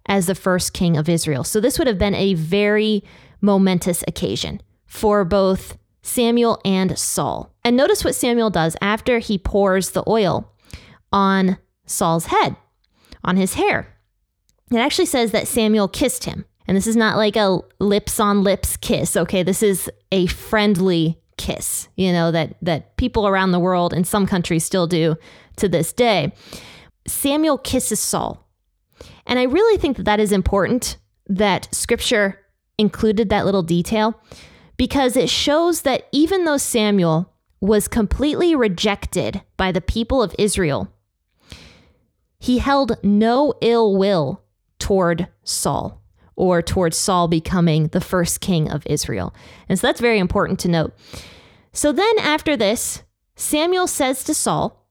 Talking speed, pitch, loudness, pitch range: 150 wpm, 200 Hz, -19 LUFS, 175-230 Hz